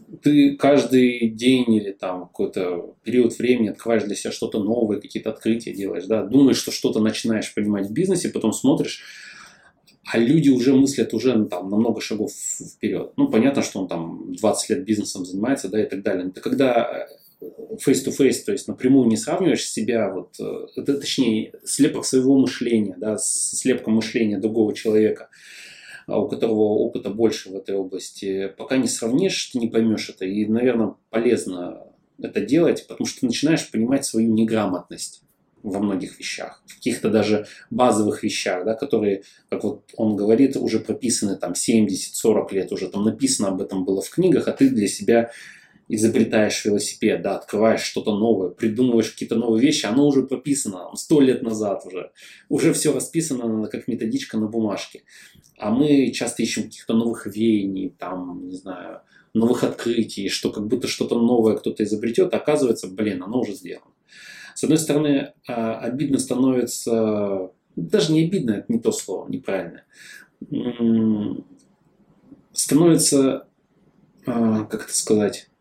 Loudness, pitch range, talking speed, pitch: -21 LUFS, 105-125 Hz, 155 wpm, 115 Hz